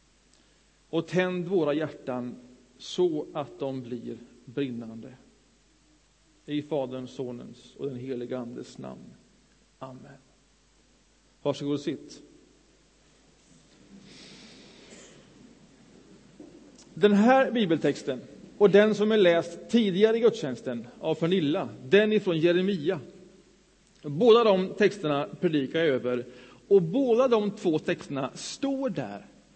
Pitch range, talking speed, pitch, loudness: 135-200 Hz, 100 wpm, 165 Hz, -26 LUFS